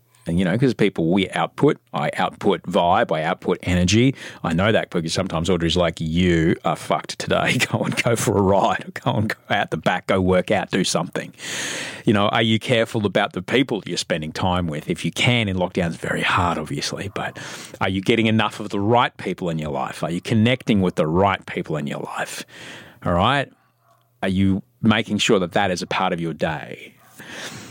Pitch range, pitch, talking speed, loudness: 90-115 Hz, 100 Hz, 210 wpm, -21 LUFS